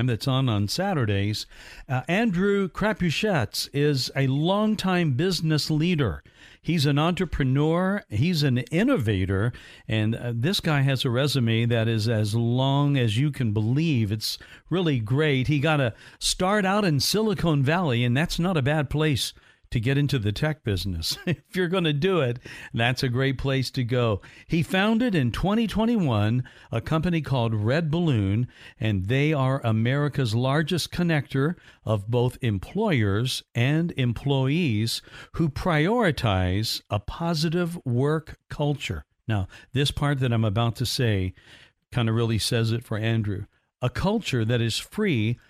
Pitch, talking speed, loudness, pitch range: 135 Hz, 150 wpm, -24 LUFS, 115-160 Hz